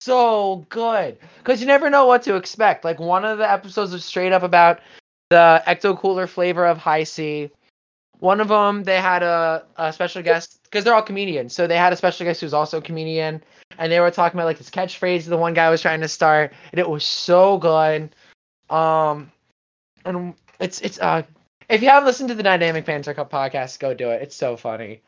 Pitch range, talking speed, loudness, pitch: 155-190 Hz, 215 wpm, -18 LUFS, 170 Hz